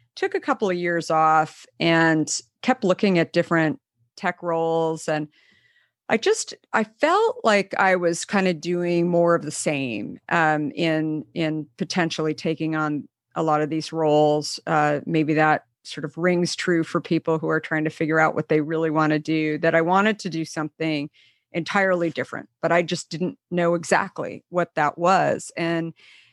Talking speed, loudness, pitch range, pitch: 180 wpm, -22 LUFS, 155-175 Hz, 165 Hz